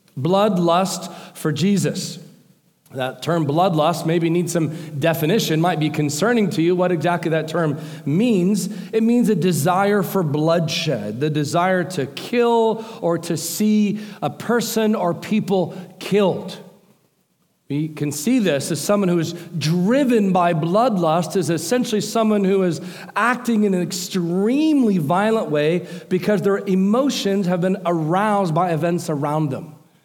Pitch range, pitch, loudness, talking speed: 165-205 Hz, 180 Hz, -19 LUFS, 140 wpm